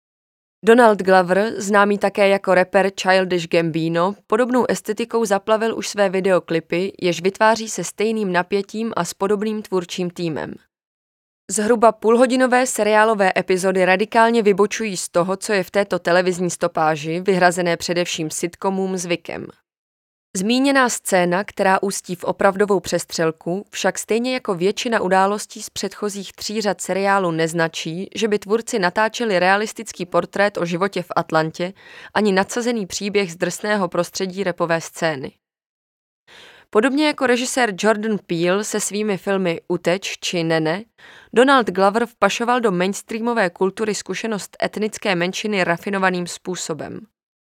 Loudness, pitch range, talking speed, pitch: -19 LUFS, 180-215 Hz, 125 wpm, 195 Hz